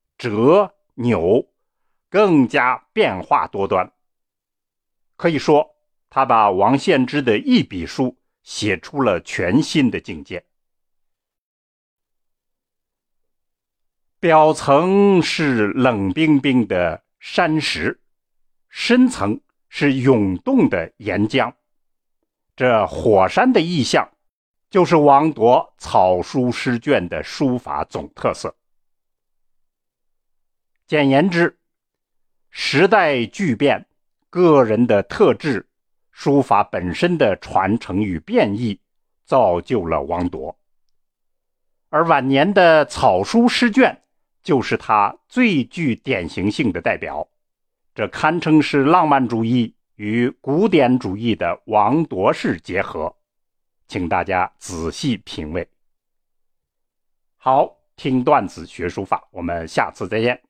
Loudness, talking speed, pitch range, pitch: -18 LUFS, 150 characters per minute, 110-165 Hz, 140 Hz